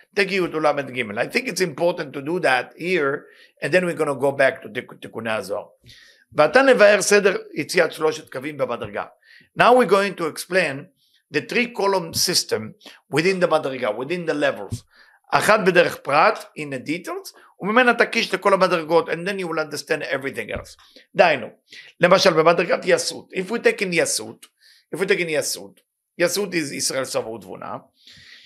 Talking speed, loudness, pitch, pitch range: 135 wpm, -20 LUFS, 180 Hz, 155-210 Hz